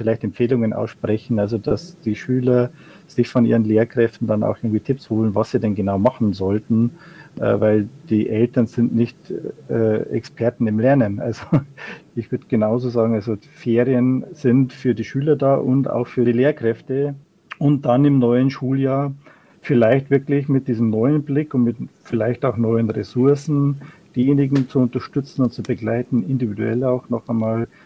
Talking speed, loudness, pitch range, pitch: 160 wpm, -19 LUFS, 115-135 Hz, 120 Hz